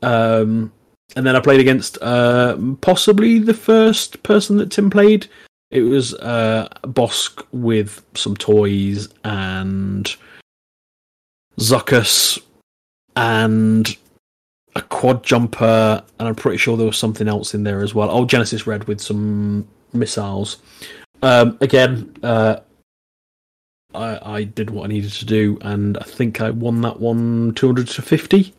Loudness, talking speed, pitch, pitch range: -17 LUFS, 140 wpm, 115 Hz, 105-130 Hz